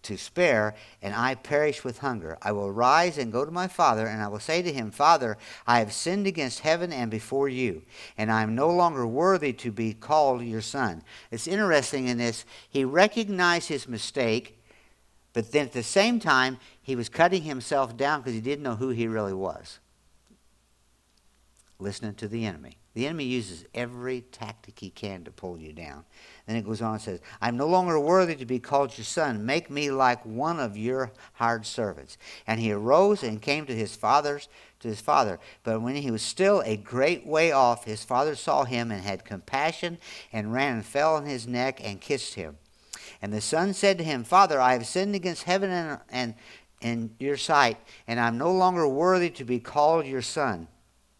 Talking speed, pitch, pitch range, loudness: 200 wpm, 125 Hz, 110-150 Hz, -26 LUFS